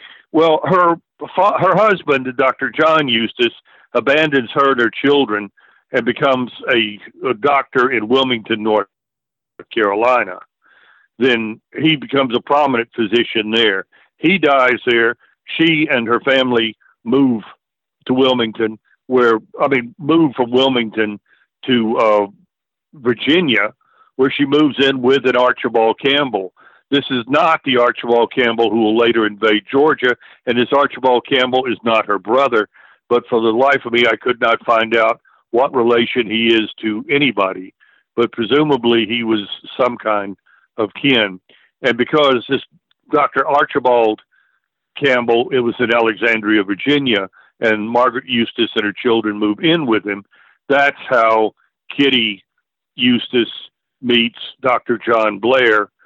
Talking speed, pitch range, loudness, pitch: 135 wpm, 115-135 Hz, -15 LUFS, 120 Hz